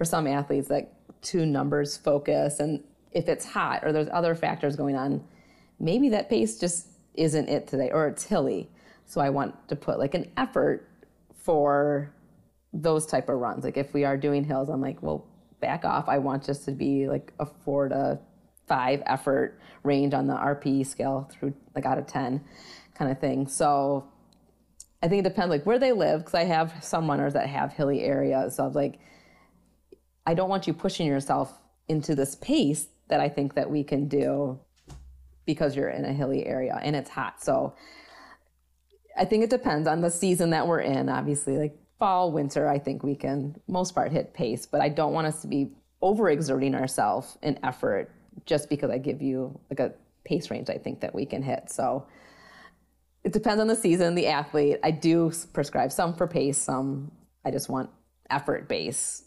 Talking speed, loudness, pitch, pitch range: 195 wpm, -27 LUFS, 145 Hz, 140-165 Hz